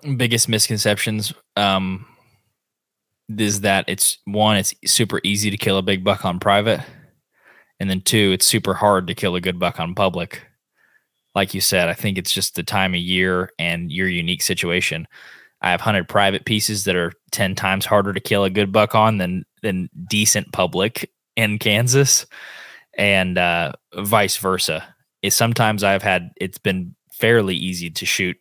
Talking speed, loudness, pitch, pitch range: 170 wpm, -19 LUFS, 100 Hz, 95-110 Hz